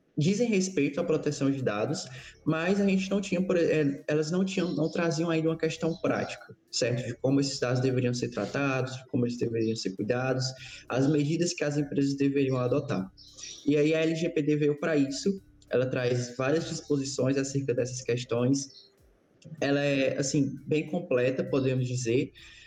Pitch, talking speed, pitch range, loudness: 140 Hz, 160 wpm, 130-160 Hz, -28 LUFS